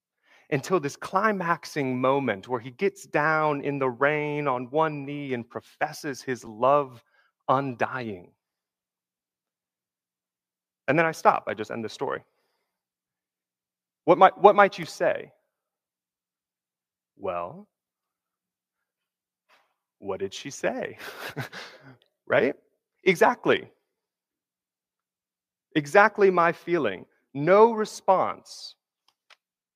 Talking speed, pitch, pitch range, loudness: 95 wpm, 150 Hz, 130-190 Hz, -24 LUFS